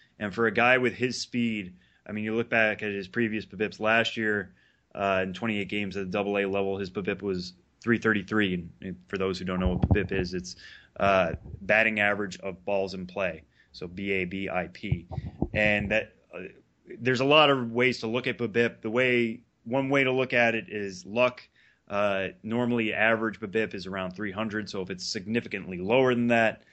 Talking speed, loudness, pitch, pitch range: 195 wpm, -27 LUFS, 105 Hz, 95-115 Hz